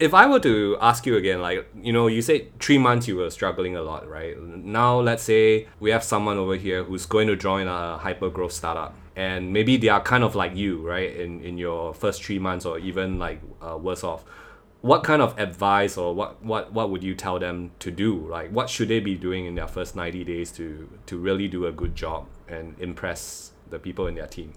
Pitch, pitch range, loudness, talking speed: 95 Hz, 90-110 Hz, -24 LUFS, 235 wpm